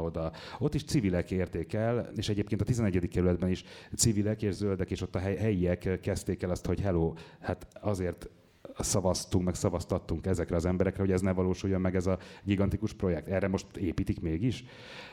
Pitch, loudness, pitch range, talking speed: 95 Hz, -31 LUFS, 90-100 Hz, 180 wpm